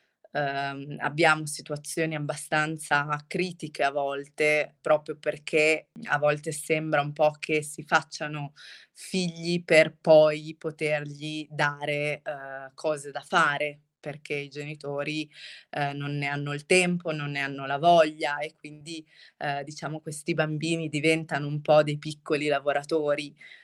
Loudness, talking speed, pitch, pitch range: -27 LUFS, 130 wpm, 150 Hz, 145-155 Hz